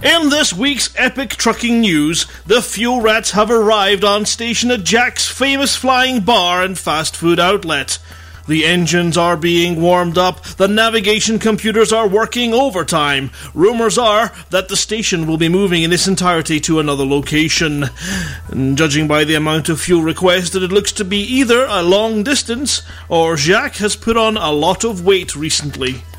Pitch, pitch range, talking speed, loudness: 190 Hz, 160-225 Hz, 170 wpm, -14 LUFS